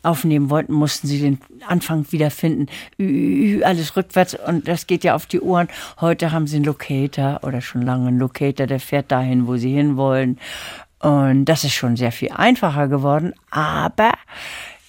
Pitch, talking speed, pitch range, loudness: 145 Hz, 170 wpm, 130-165 Hz, -19 LUFS